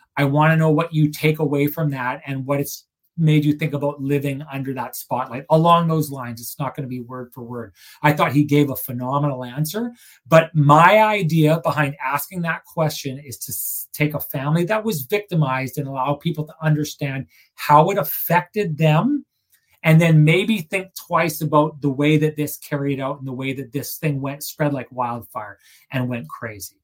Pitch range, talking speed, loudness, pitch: 135-160 Hz, 195 wpm, -20 LUFS, 150 Hz